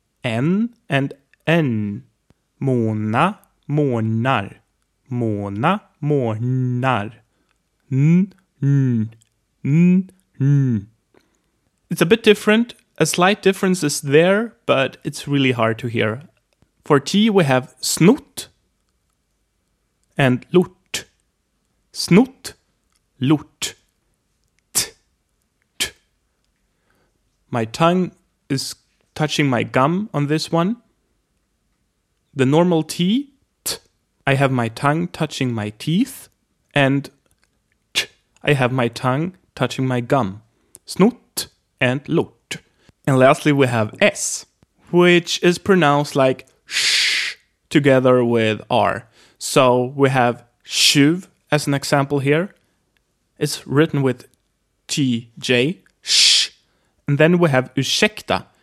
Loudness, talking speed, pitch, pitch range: -18 LUFS, 95 wpm, 140 Hz, 125-170 Hz